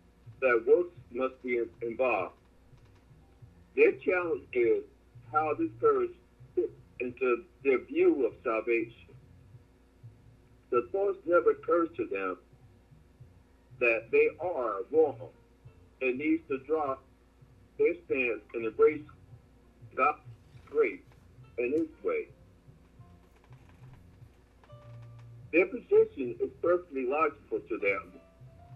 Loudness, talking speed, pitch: -30 LUFS, 100 wpm, 130 Hz